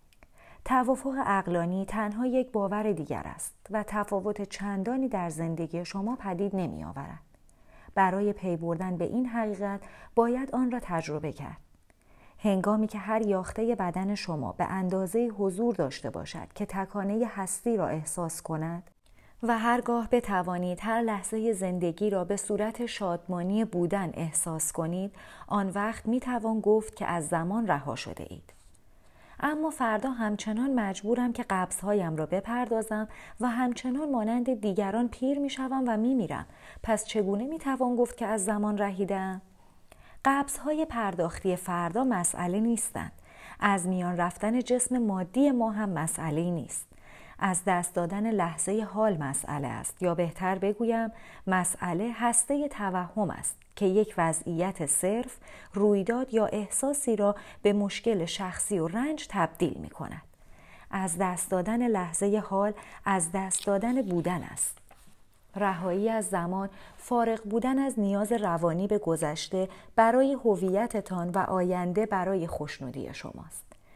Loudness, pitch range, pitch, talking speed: -29 LUFS, 180-230 Hz, 200 Hz, 135 wpm